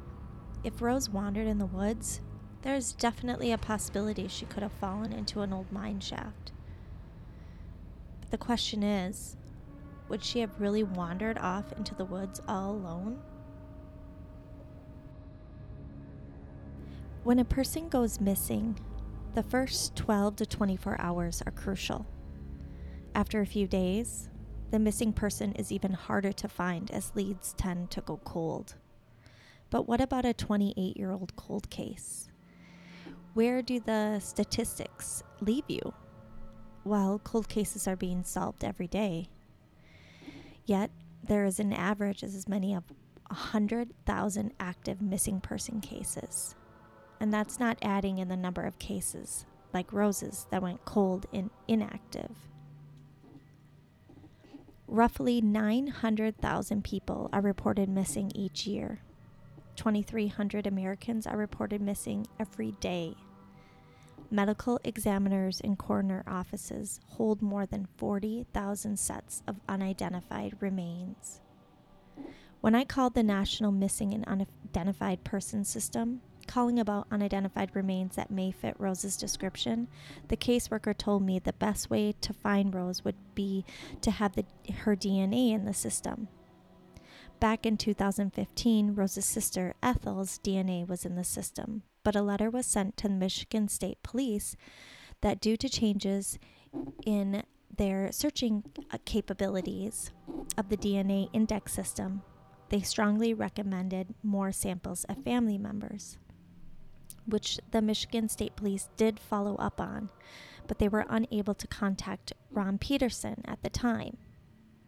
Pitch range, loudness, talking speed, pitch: 185-215 Hz, -33 LUFS, 130 wpm, 200 Hz